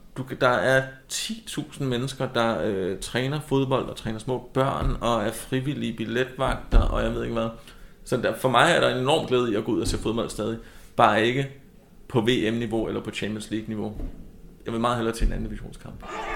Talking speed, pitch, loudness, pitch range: 195 wpm, 120 Hz, -25 LUFS, 110-130 Hz